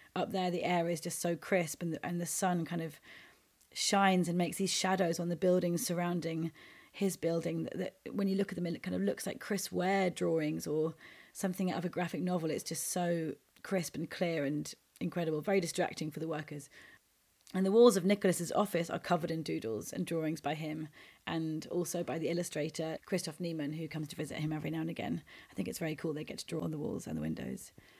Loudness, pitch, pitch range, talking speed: -35 LUFS, 170 Hz, 155-180 Hz, 225 wpm